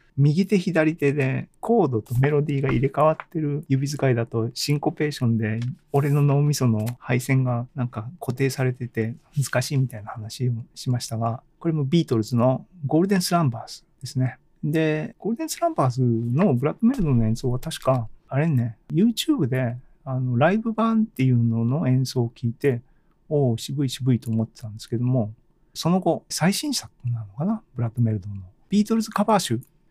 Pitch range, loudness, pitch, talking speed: 120-160 Hz, -23 LUFS, 135 Hz, 380 characters per minute